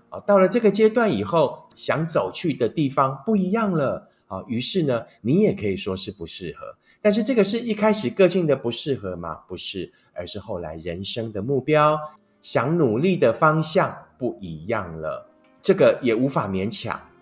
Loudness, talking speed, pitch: -22 LUFS, 260 characters per minute, 140 Hz